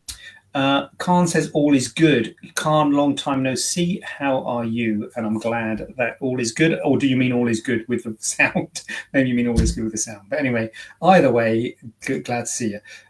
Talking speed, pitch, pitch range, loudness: 225 wpm, 125 Hz, 115-140 Hz, -21 LUFS